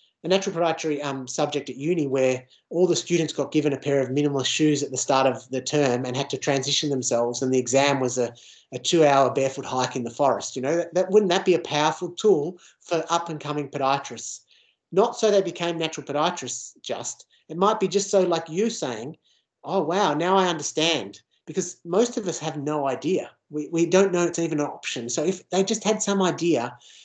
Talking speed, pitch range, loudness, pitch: 215 wpm, 135-175 Hz, -24 LUFS, 150 Hz